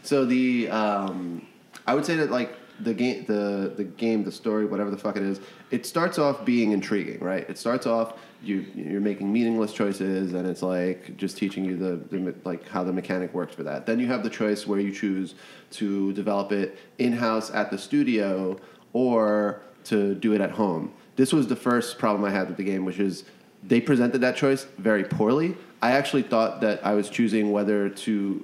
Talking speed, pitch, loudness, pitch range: 205 wpm, 105 Hz, -26 LUFS, 95-115 Hz